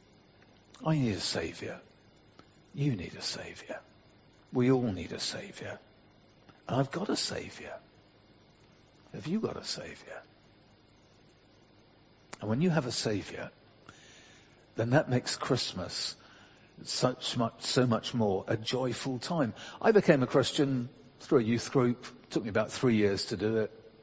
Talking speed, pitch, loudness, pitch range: 145 wpm, 125 Hz, -31 LUFS, 110-135 Hz